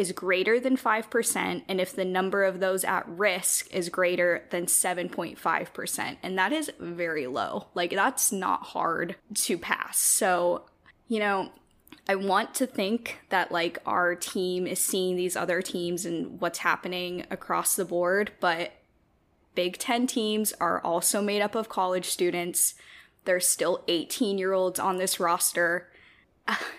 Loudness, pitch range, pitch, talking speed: -27 LUFS, 175-205 Hz, 185 Hz, 155 wpm